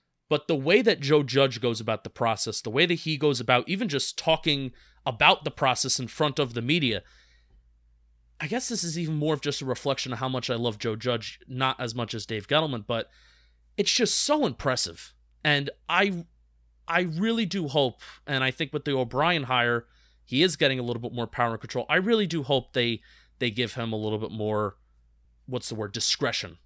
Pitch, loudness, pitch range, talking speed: 125 Hz, -26 LUFS, 110-155 Hz, 210 wpm